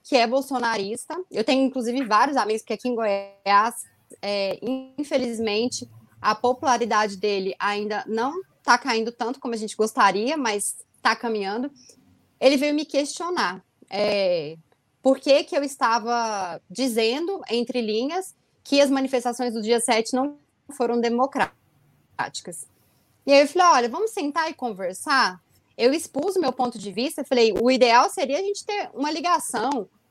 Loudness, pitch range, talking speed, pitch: -23 LUFS, 220-275 Hz, 155 wpm, 245 Hz